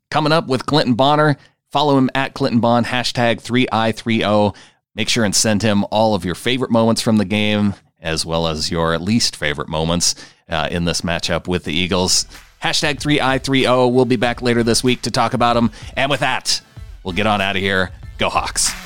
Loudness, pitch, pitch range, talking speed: -17 LUFS, 110 Hz, 90-125 Hz, 215 wpm